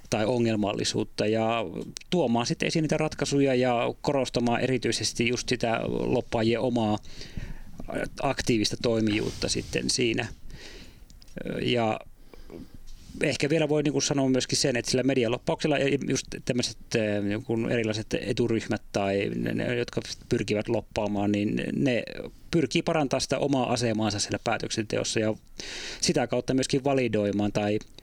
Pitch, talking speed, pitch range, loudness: 120 Hz, 120 wpm, 110-135 Hz, -27 LUFS